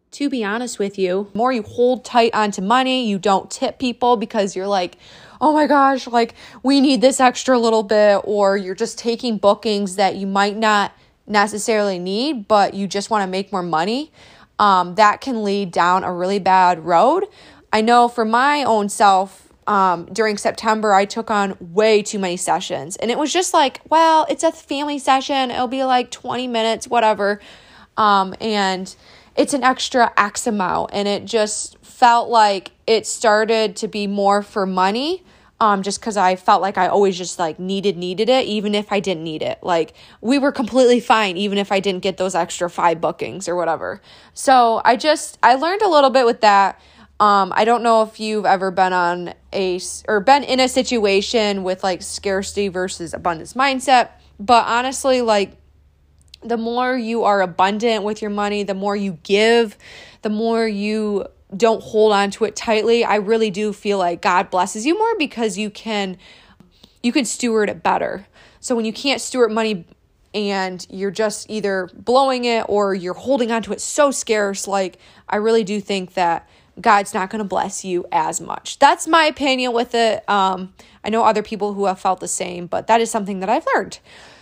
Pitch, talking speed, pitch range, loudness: 215 Hz, 200 wpm, 195-235 Hz, -18 LUFS